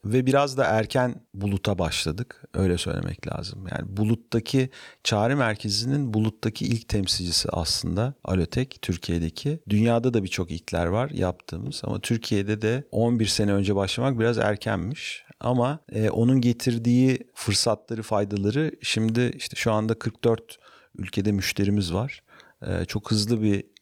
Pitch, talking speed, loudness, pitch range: 110 Hz, 130 wpm, -25 LUFS, 100-120 Hz